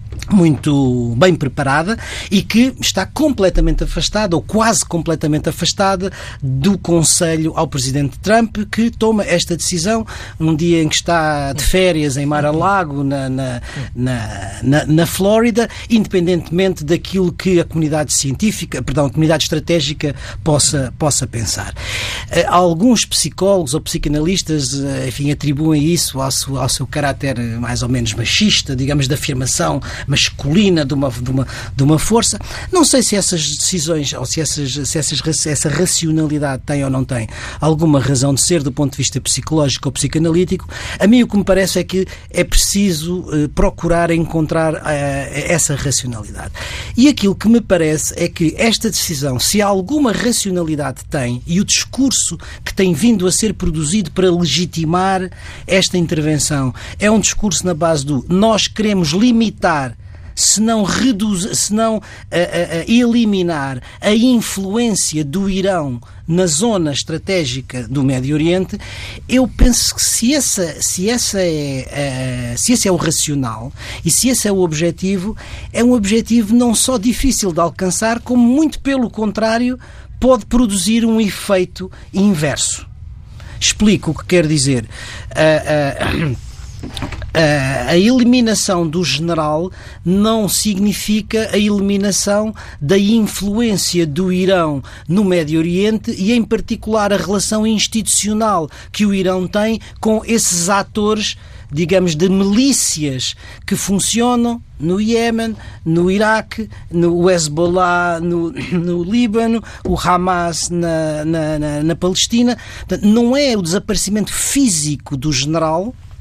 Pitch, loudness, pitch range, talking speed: 170 Hz, -15 LUFS, 145-205 Hz, 140 wpm